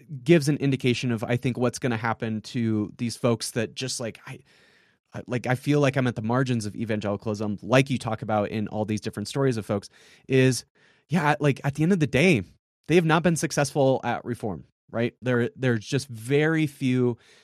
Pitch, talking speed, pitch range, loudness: 125 Hz, 205 wpm, 110-140 Hz, -25 LUFS